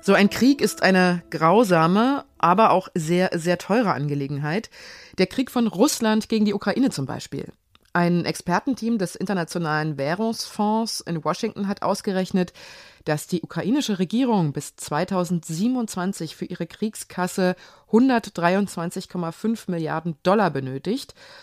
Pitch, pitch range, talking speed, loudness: 185 Hz, 170-220 Hz, 120 wpm, -23 LUFS